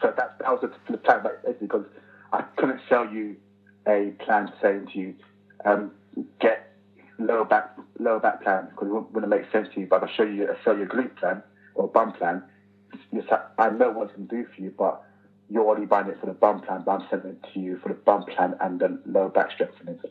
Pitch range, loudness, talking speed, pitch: 100-105 Hz, -25 LUFS, 220 wpm, 100 Hz